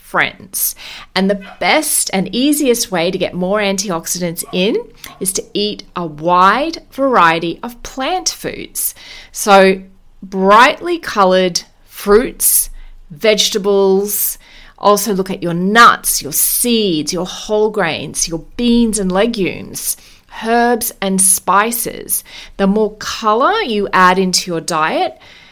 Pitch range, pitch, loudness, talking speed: 185-220 Hz, 200 Hz, -14 LUFS, 120 wpm